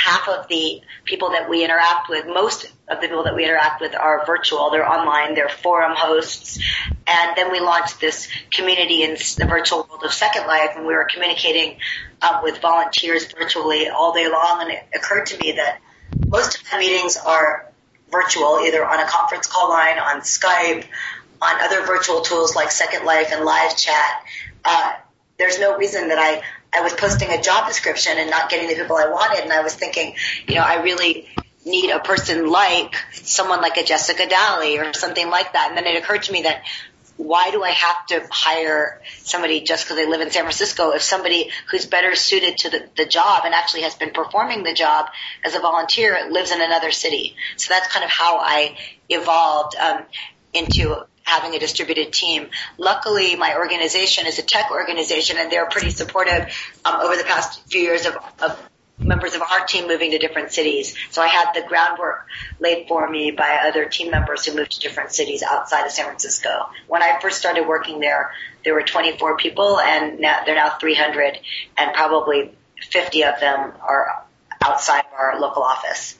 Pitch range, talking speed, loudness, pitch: 155-180 Hz, 195 wpm, -18 LUFS, 165 Hz